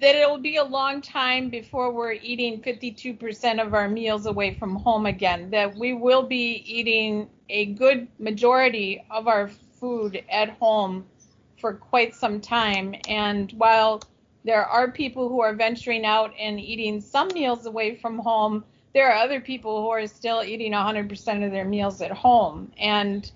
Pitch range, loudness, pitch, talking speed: 210-245 Hz, -23 LUFS, 225 Hz, 170 wpm